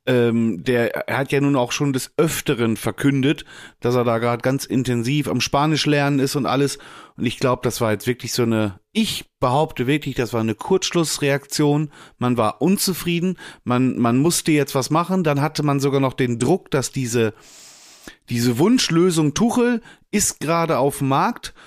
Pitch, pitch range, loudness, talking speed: 140 Hz, 125-155 Hz, -20 LUFS, 180 wpm